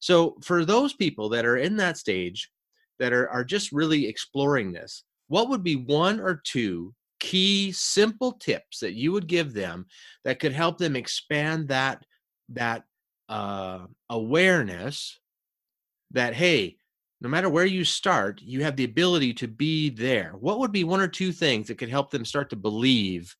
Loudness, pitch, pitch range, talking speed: -25 LUFS, 150 Hz, 120-180 Hz, 170 wpm